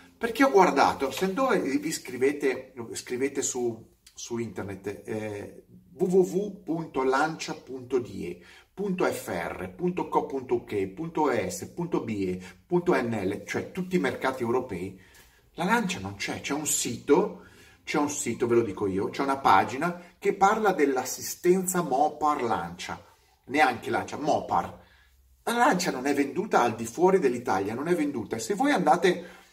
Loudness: -27 LUFS